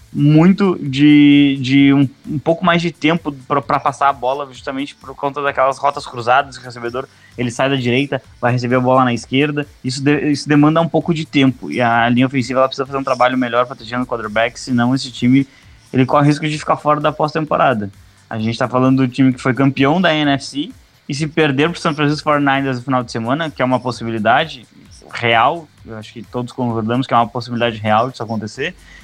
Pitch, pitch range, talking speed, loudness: 135 Hz, 125-145 Hz, 215 wpm, -16 LUFS